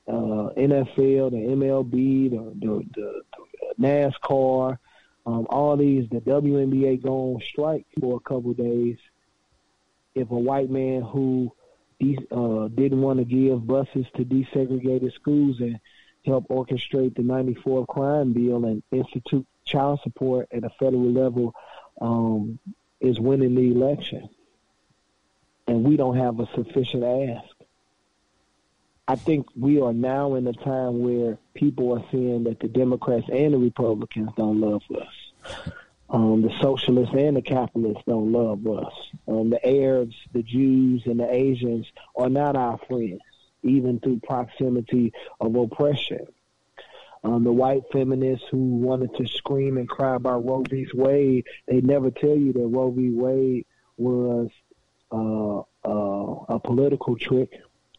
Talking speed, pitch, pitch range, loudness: 140 wpm, 125 Hz, 120-135 Hz, -23 LUFS